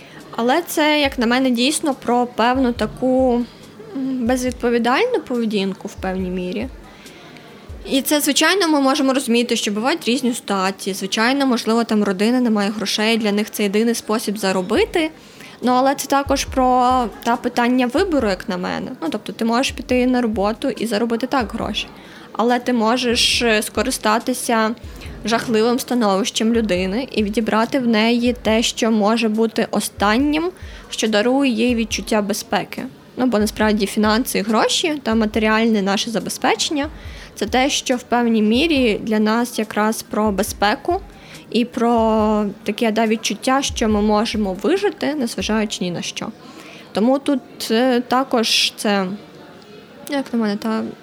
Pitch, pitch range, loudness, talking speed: 230 Hz, 215-255 Hz, -18 LUFS, 145 wpm